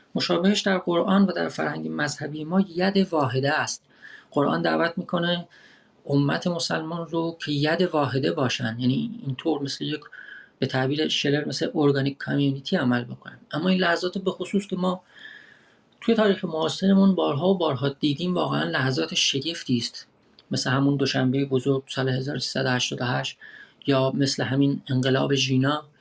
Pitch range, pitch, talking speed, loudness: 135-180 Hz, 150 Hz, 145 wpm, -24 LUFS